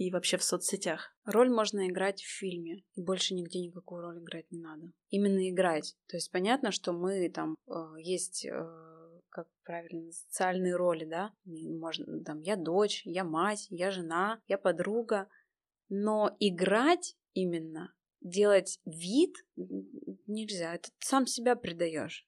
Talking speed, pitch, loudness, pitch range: 140 wpm, 185 Hz, -32 LUFS, 170-205 Hz